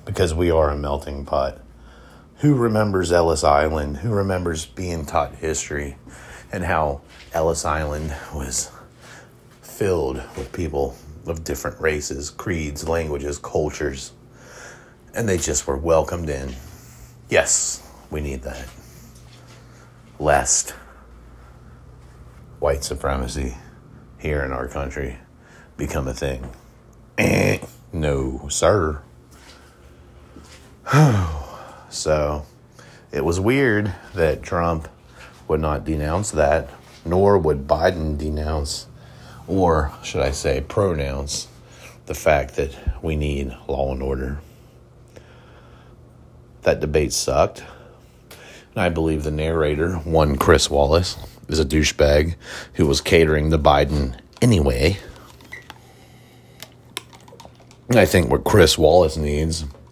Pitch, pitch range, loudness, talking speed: 75 Hz, 70-85 Hz, -21 LUFS, 105 wpm